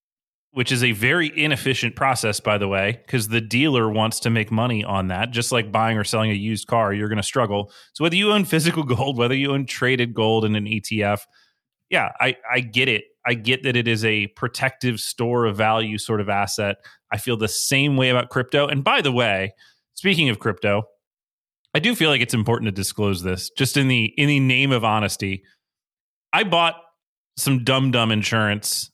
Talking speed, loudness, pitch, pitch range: 205 wpm, -20 LUFS, 115 Hz, 105-130 Hz